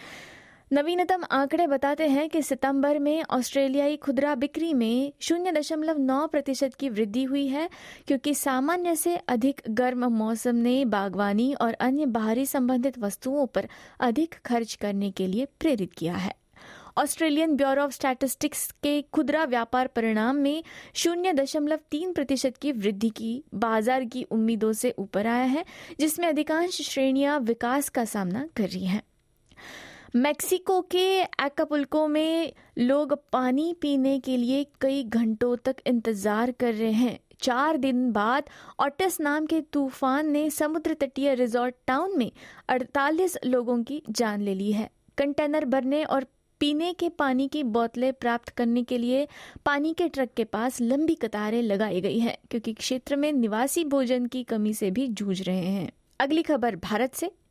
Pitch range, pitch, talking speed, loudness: 235-295 Hz, 270 Hz, 155 wpm, -26 LUFS